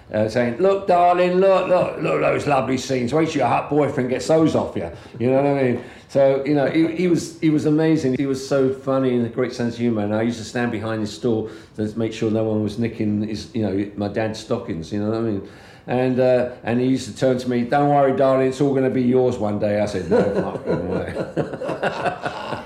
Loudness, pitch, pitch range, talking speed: -20 LUFS, 125 Hz, 110-135 Hz, 255 wpm